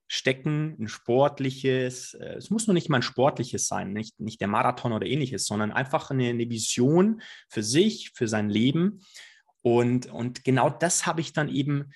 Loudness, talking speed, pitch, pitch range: -26 LUFS, 175 wpm, 130 Hz, 120-160 Hz